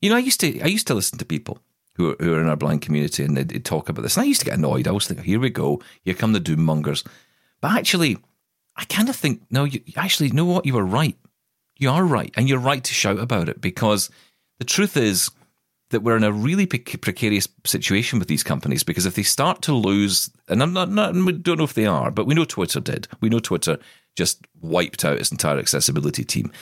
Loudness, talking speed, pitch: -21 LUFS, 250 wpm, 125 Hz